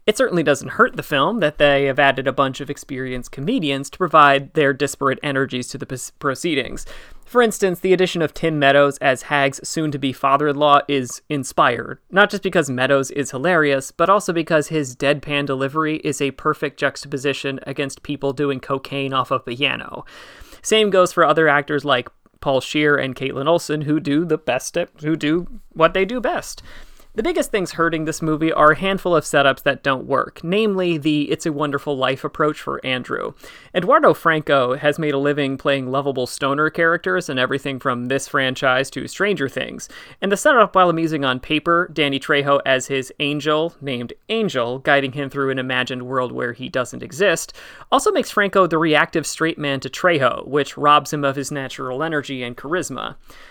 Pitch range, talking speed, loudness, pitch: 135-160 Hz, 185 wpm, -19 LUFS, 145 Hz